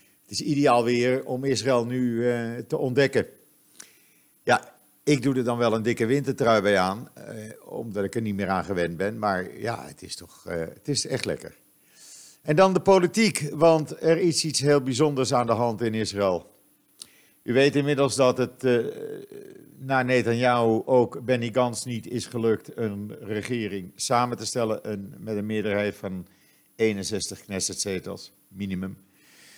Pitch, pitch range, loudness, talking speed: 120 Hz, 105-135 Hz, -25 LUFS, 165 wpm